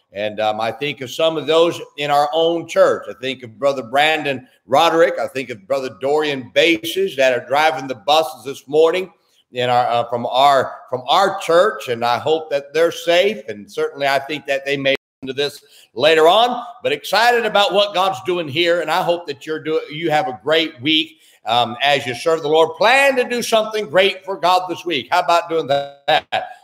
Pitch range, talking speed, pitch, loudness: 135-175 Hz, 210 wpm, 155 Hz, -17 LUFS